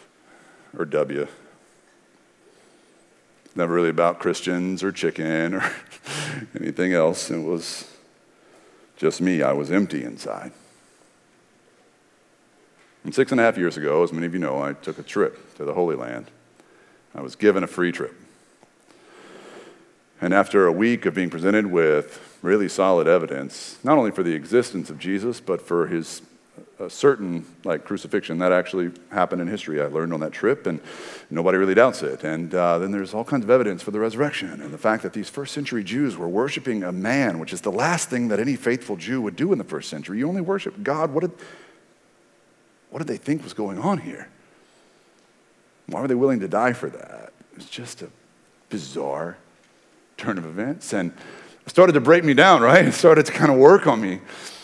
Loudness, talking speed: -21 LUFS, 185 wpm